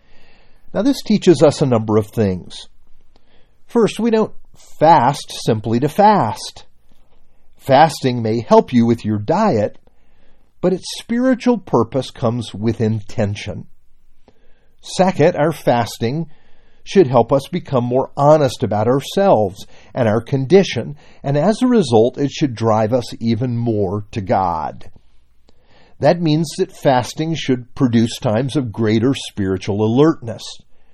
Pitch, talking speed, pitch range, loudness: 125 Hz, 130 wpm, 110-160 Hz, -16 LUFS